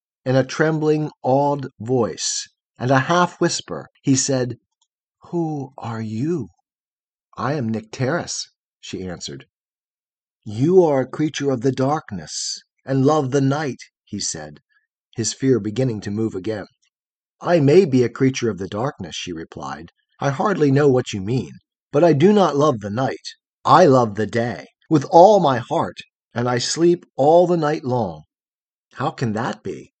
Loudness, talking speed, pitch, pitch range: -19 LUFS, 160 wpm, 130 Hz, 115-155 Hz